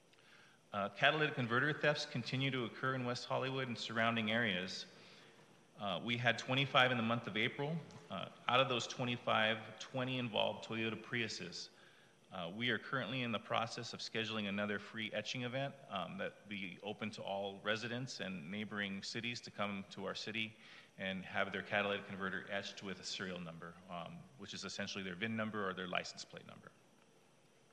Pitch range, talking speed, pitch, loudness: 100-125 Hz, 175 wpm, 110 Hz, -39 LUFS